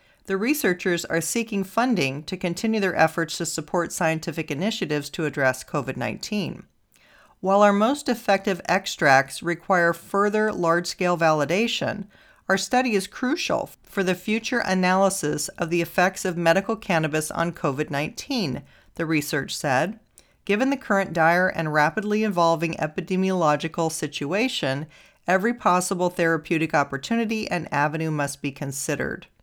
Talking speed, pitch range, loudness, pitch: 135 wpm, 155-200 Hz, -23 LUFS, 175 Hz